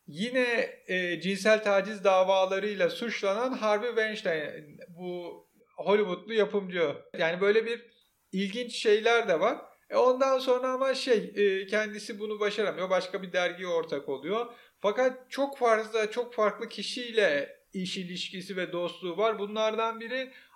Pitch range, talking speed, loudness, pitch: 195-245 Hz, 130 wpm, -29 LUFS, 215 Hz